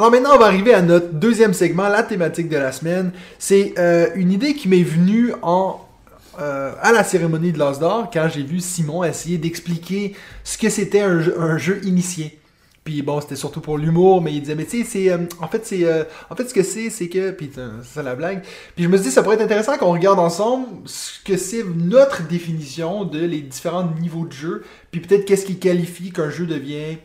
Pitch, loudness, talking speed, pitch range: 175 Hz, -18 LUFS, 220 wpm, 160-195 Hz